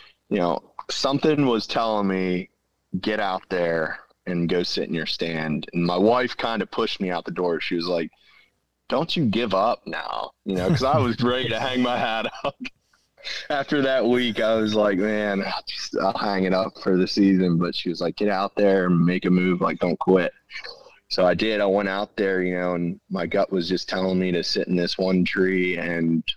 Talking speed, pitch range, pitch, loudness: 220 wpm, 90-110 Hz, 95 Hz, -23 LUFS